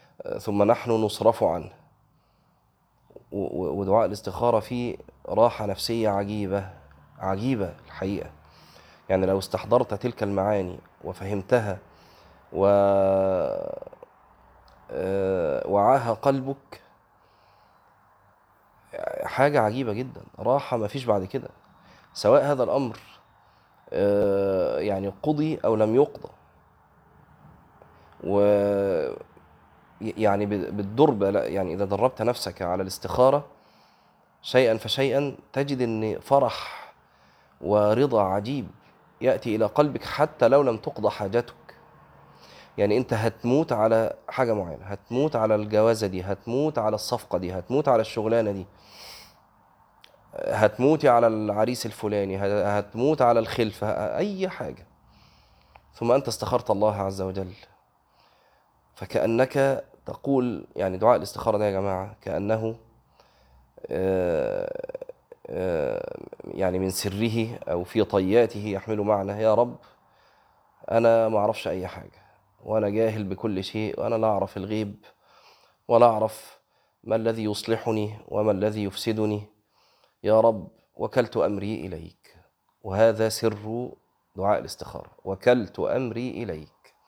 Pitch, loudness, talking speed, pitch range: 110 Hz, -25 LUFS, 100 wpm, 100-120 Hz